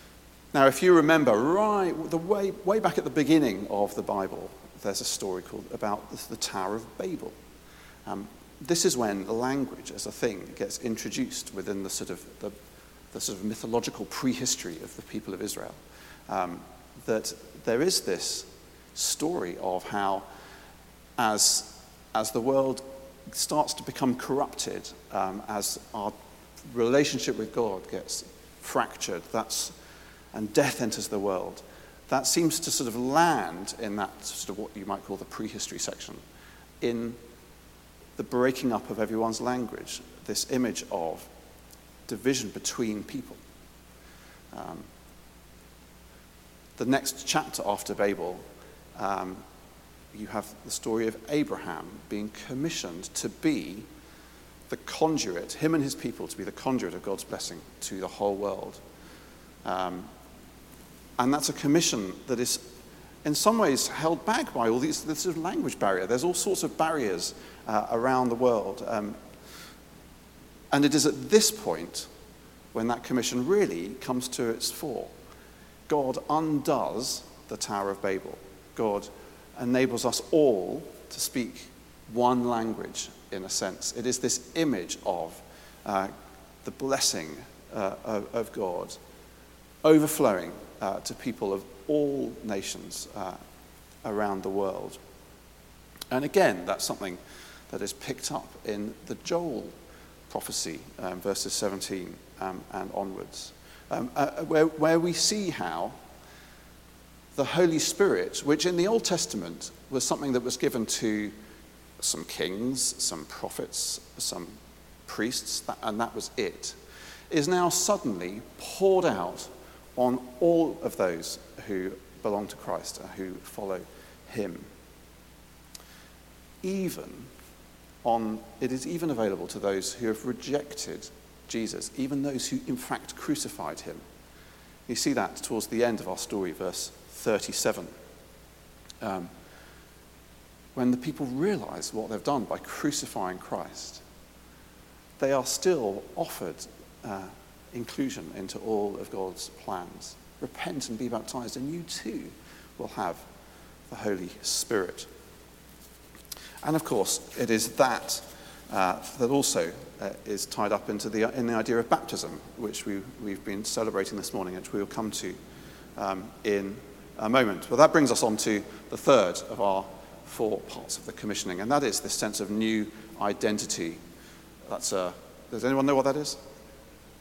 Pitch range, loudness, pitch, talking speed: 95-140 Hz, -29 LUFS, 115 Hz, 145 wpm